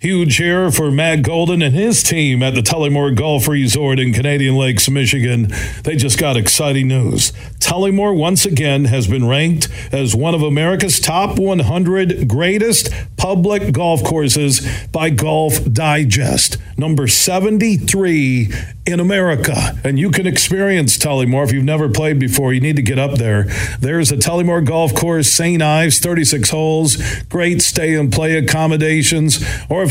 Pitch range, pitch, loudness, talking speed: 130-165 Hz, 145 Hz, -14 LUFS, 155 wpm